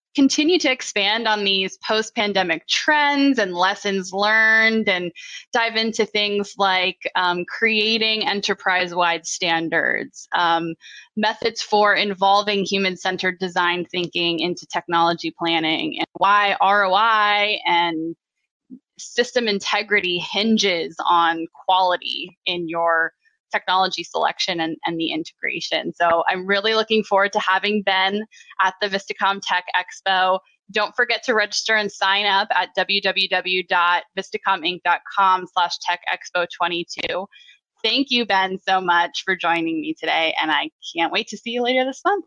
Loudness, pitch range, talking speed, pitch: -20 LUFS, 175-220 Hz, 130 wpm, 195 Hz